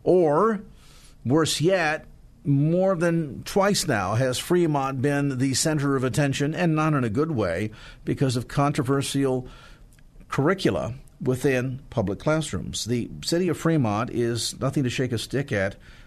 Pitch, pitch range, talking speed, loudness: 140 Hz, 125-155 Hz, 140 wpm, -24 LUFS